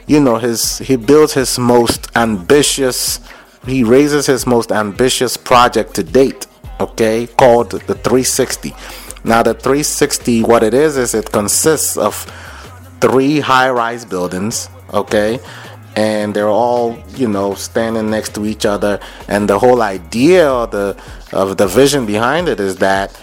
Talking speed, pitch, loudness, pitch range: 150 wpm, 115 Hz, -13 LUFS, 105-125 Hz